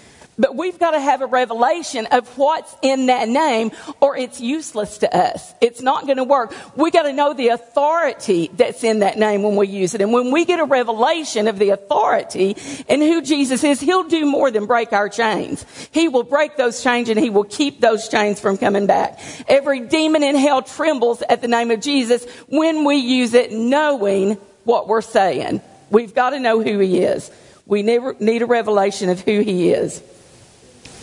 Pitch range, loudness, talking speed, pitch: 220-285 Hz, -17 LUFS, 200 wpm, 245 Hz